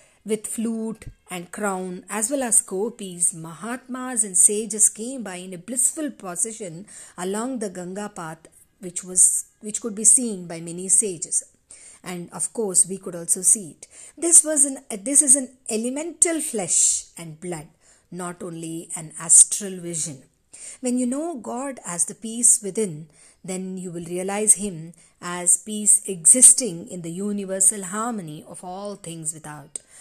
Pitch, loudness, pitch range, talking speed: 195 Hz, -19 LUFS, 175-225 Hz, 155 wpm